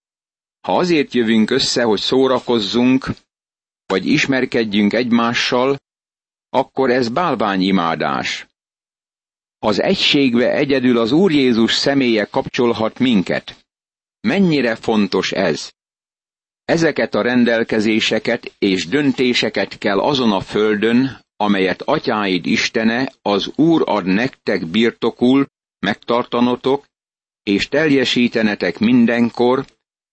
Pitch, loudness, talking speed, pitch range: 120 Hz, -16 LUFS, 90 wpm, 110-130 Hz